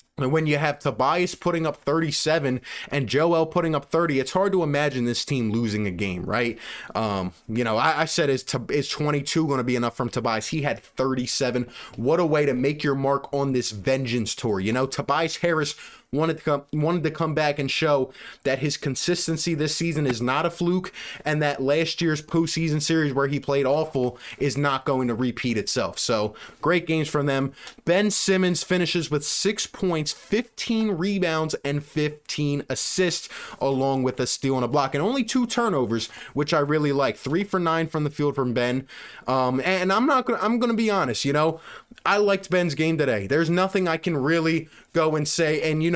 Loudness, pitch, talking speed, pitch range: -24 LUFS, 150 Hz, 205 wpm, 135-170 Hz